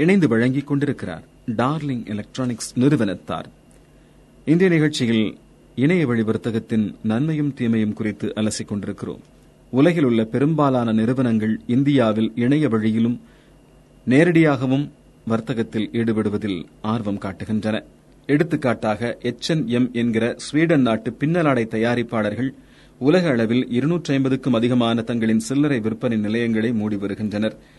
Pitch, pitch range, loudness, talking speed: 115 Hz, 110-135 Hz, -21 LUFS, 90 wpm